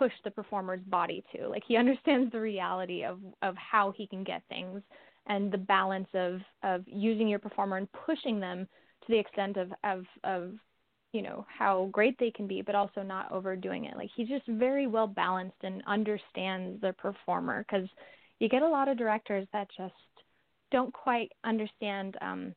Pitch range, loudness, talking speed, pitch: 190-225 Hz, -32 LUFS, 185 wpm, 200 Hz